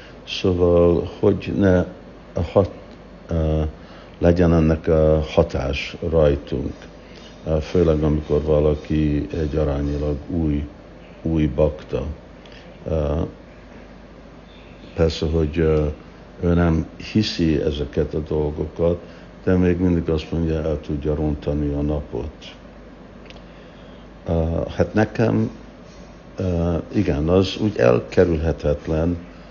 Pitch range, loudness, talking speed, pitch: 75-85 Hz, -21 LUFS, 85 wpm, 80 Hz